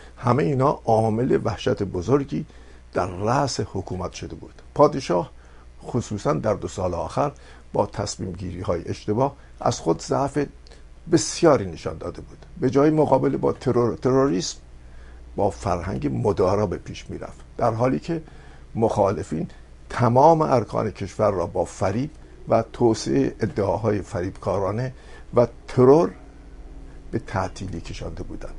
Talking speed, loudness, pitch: 130 wpm, -23 LUFS, 110 Hz